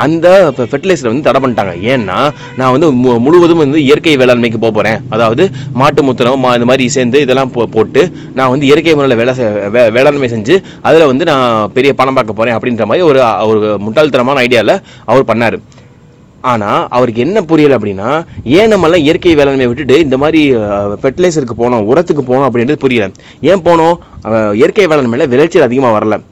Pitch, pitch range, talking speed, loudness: 130 Hz, 115-155 Hz, 160 wpm, -9 LUFS